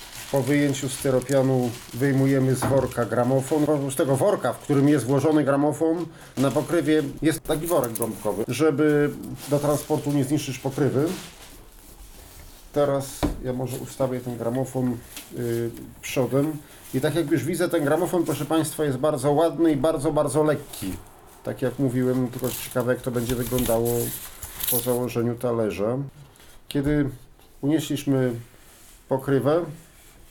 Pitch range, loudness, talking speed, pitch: 125-150 Hz, -24 LUFS, 135 wpm, 135 Hz